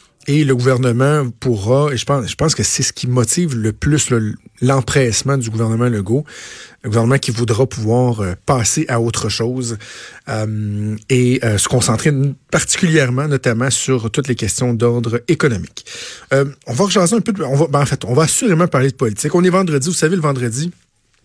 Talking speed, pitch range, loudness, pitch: 190 wpm, 115-145 Hz, -16 LUFS, 130 Hz